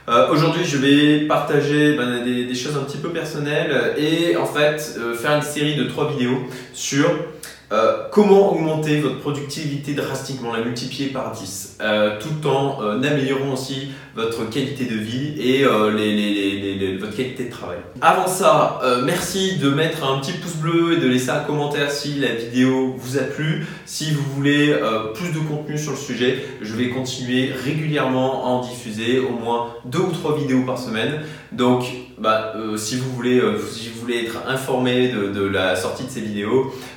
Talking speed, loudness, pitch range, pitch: 195 wpm, -20 LUFS, 120-150 Hz, 130 Hz